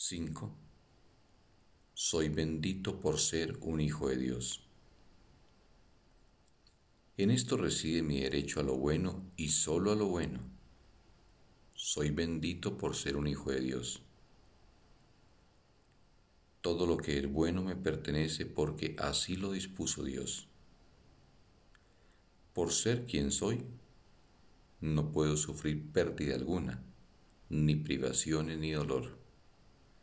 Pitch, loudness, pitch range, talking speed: 80 Hz, -35 LUFS, 70-90 Hz, 110 wpm